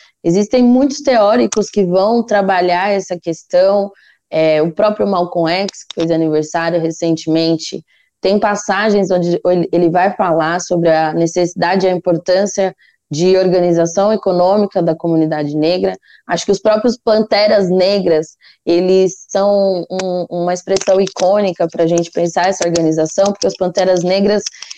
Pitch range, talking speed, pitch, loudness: 170-200 Hz, 140 wpm, 180 Hz, -14 LUFS